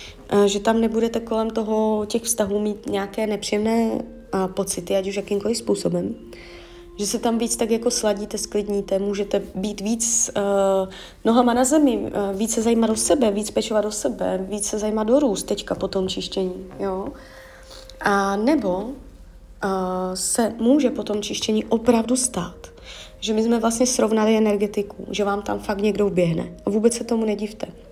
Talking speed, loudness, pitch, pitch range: 165 wpm, -22 LUFS, 215 Hz, 200-230 Hz